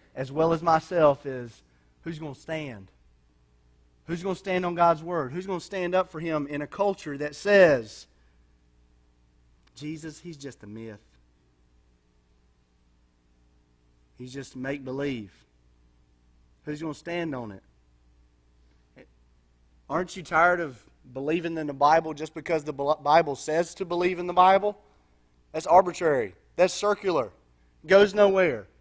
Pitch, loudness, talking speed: 130 Hz, -25 LUFS, 140 wpm